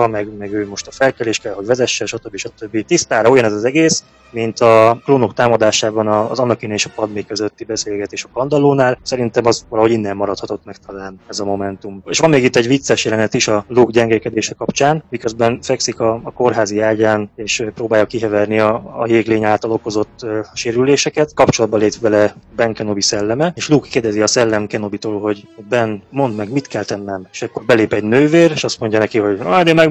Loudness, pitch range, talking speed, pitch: -15 LUFS, 105-125 Hz, 200 wpm, 110 Hz